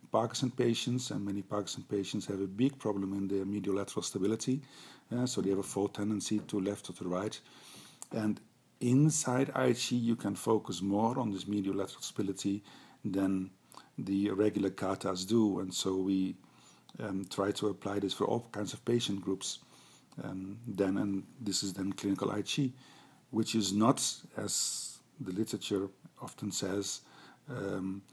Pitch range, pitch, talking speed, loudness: 95-115 Hz, 100 Hz, 155 wpm, -34 LUFS